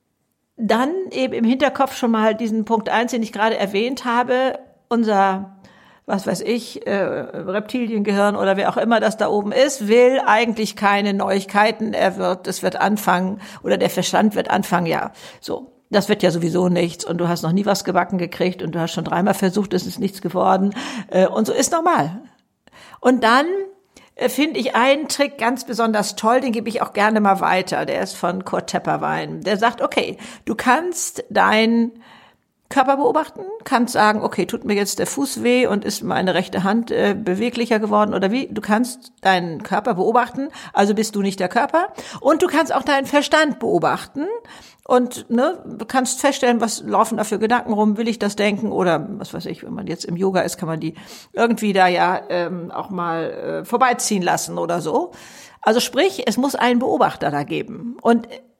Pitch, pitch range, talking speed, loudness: 220 Hz, 195-250 Hz, 190 wpm, -19 LUFS